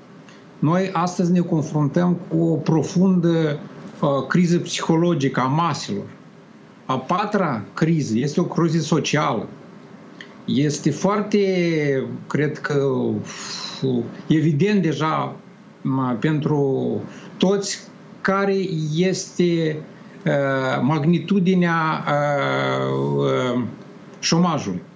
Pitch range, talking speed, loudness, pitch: 145-185 Hz, 75 wpm, -21 LUFS, 165 Hz